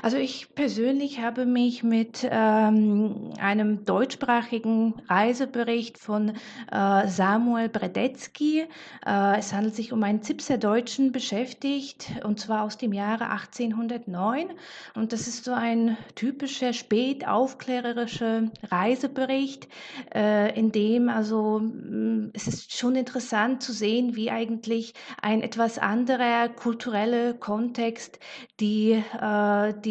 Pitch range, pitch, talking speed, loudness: 215-250 Hz, 230 Hz, 115 wpm, -26 LUFS